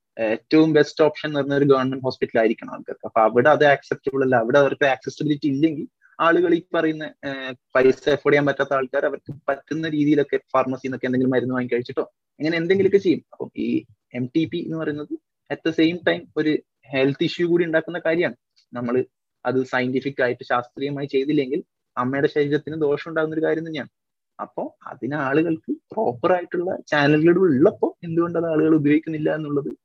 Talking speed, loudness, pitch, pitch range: 155 wpm, -21 LUFS, 145 Hz, 130-160 Hz